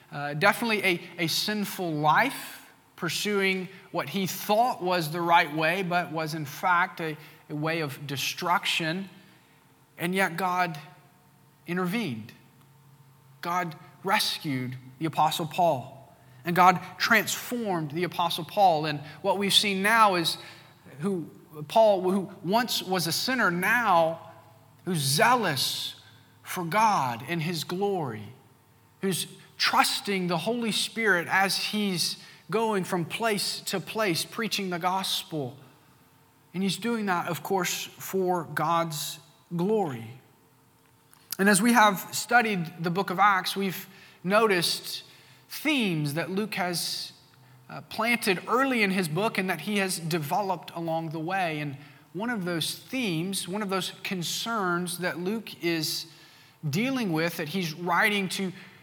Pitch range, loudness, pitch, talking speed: 155-195 Hz, -26 LUFS, 175 Hz, 130 wpm